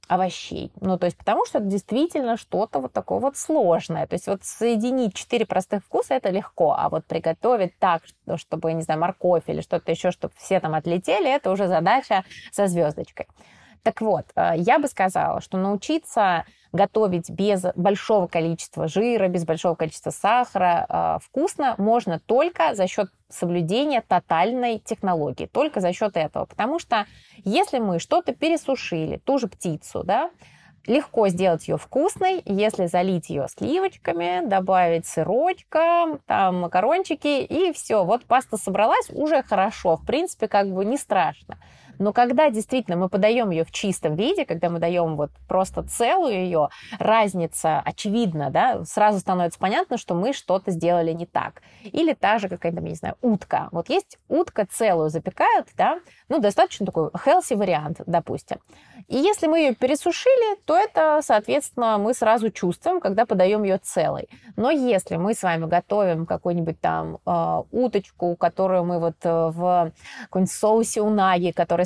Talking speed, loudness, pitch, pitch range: 155 wpm, -22 LUFS, 200 Hz, 175-250 Hz